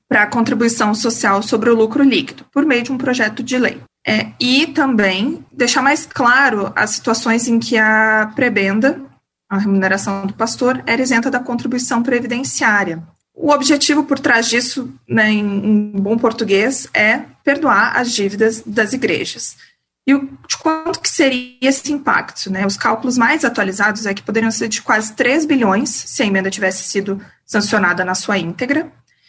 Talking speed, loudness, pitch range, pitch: 170 wpm, -15 LUFS, 210-265 Hz, 235 Hz